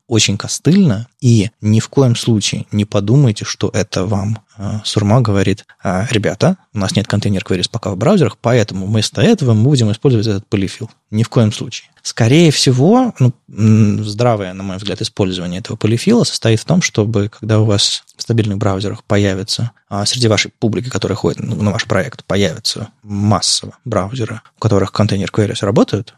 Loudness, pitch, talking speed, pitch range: -15 LUFS, 110 Hz, 160 wpm, 100-120 Hz